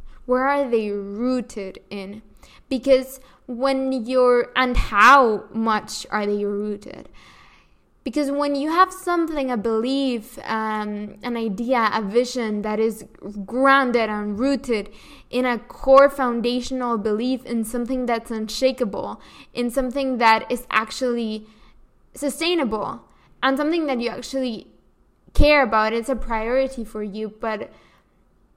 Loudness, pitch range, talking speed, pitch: -21 LUFS, 220-265 Hz, 125 wpm, 245 Hz